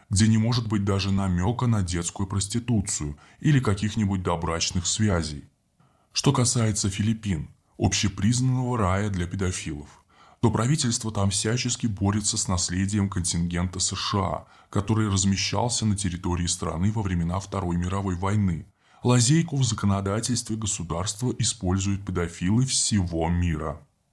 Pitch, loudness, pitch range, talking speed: 100 Hz, -25 LUFS, 90-110 Hz, 115 wpm